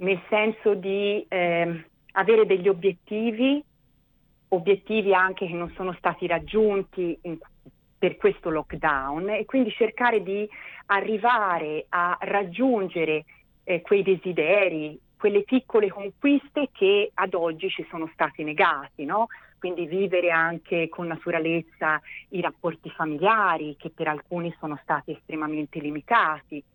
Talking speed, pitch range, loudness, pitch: 120 wpm, 160-205 Hz, -25 LUFS, 185 Hz